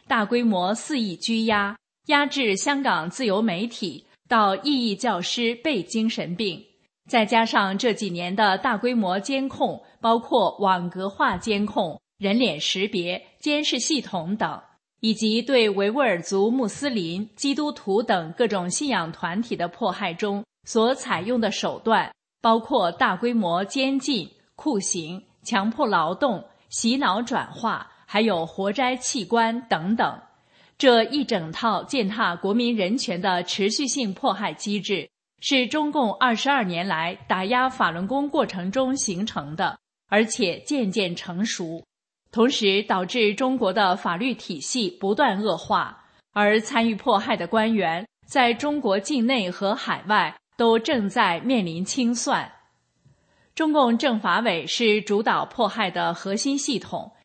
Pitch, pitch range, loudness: 220 Hz, 195-255 Hz, -23 LUFS